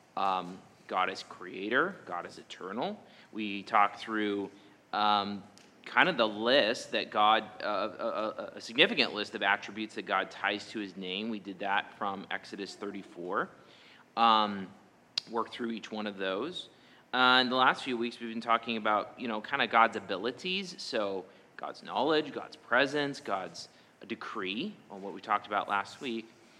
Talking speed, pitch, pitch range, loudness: 170 wpm, 105 Hz, 100-115 Hz, -31 LUFS